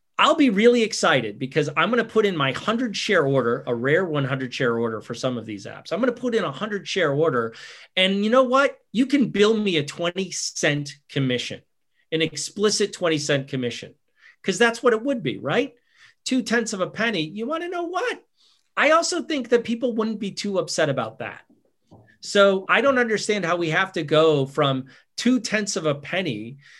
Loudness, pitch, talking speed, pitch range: -22 LUFS, 195 Hz, 210 wpm, 150-235 Hz